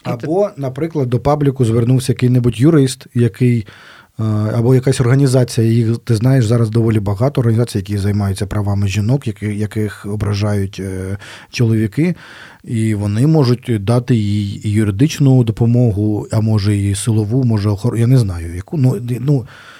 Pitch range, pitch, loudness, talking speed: 105-130 Hz, 115 Hz, -15 LUFS, 135 wpm